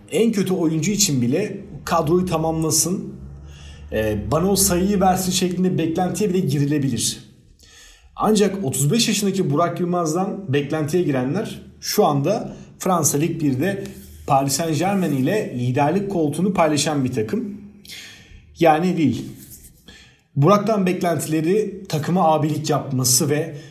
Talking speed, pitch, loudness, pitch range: 110 wpm, 160 Hz, -20 LUFS, 140-185 Hz